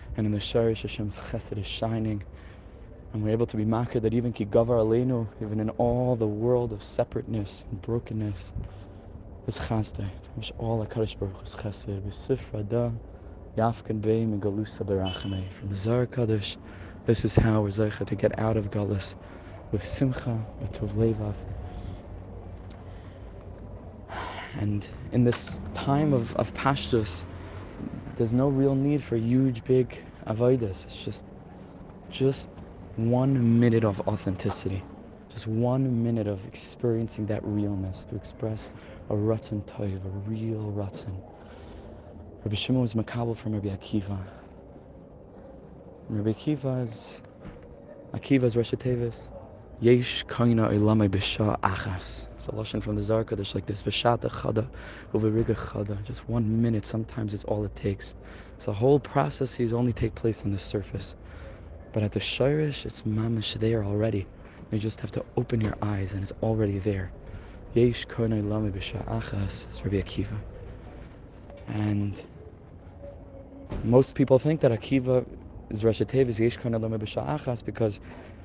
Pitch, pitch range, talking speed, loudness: 105 Hz, 100-115 Hz, 140 wpm, -28 LUFS